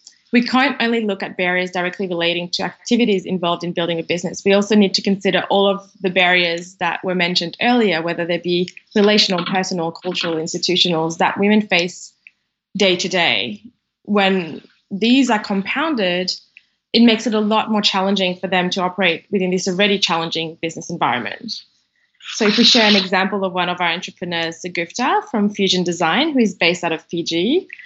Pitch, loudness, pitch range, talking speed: 190 Hz, -17 LUFS, 175-210 Hz, 180 wpm